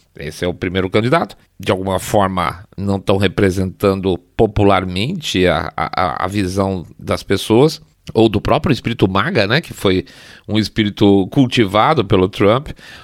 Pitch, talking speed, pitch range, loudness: 100 Hz, 145 wpm, 95-110 Hz, -16 LUFS